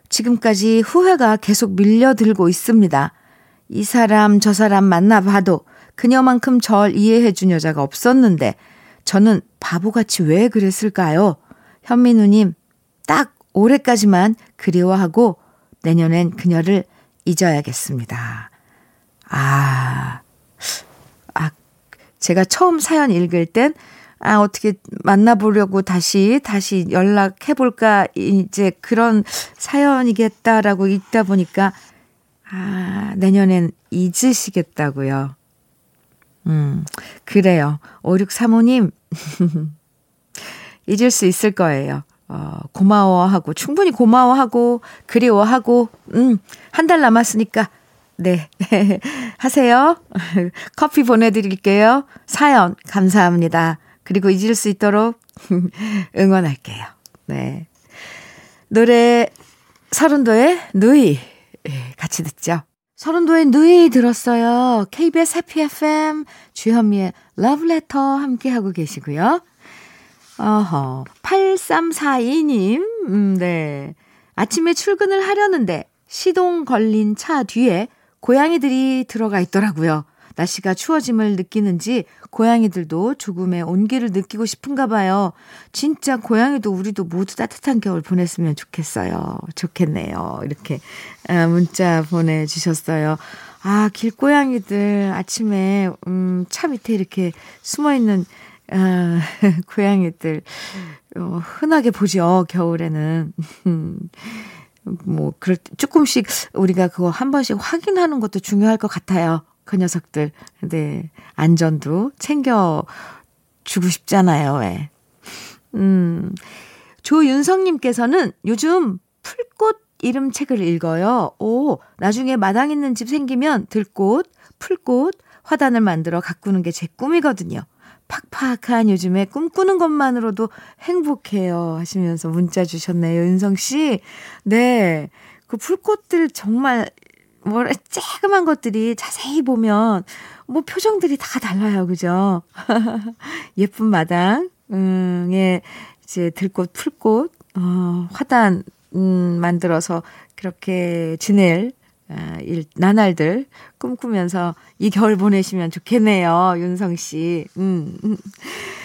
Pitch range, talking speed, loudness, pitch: 180-245 Hz, 225 characters per minute, -17 LUFS, 205 Hz